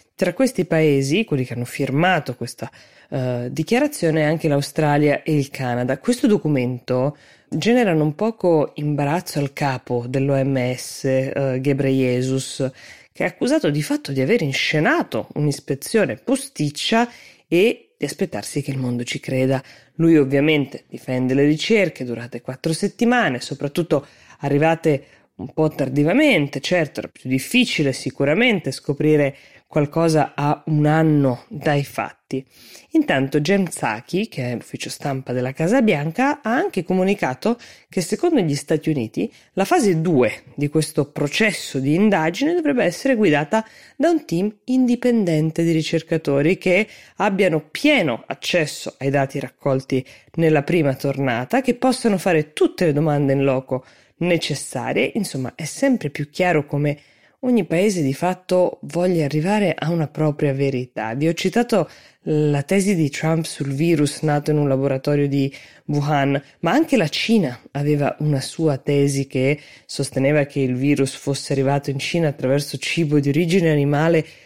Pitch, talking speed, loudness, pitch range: 150 Hz, 140 wpm, -20 LUFS, 140-180 Hz